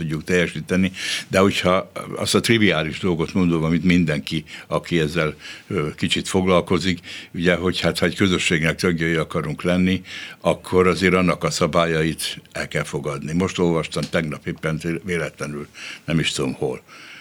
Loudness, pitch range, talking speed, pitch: -21 LUFS, 80-90 Hz, 140 wpm, 85 Hz